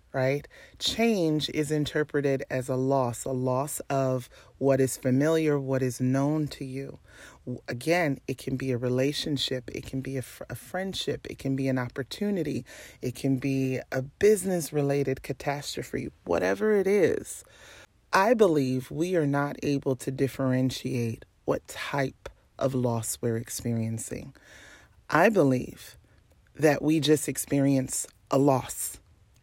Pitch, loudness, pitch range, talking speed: 135 Hz, -28 LUFS, 130-145 Hz, 135 wpm